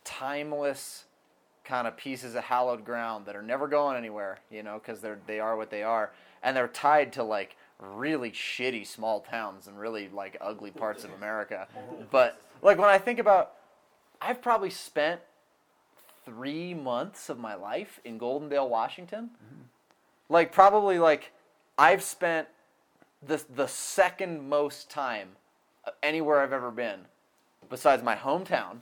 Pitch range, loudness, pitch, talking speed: 115-165 Hz, -28 LUFS, 140 Hz, 145 wpm